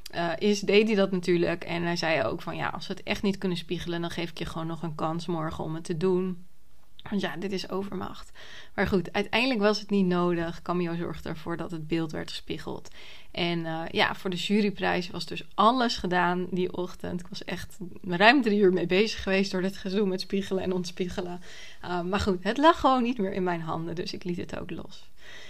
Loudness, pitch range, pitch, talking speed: -28 LUFS, 175-200 Hz, 185 Hz, 230 wpm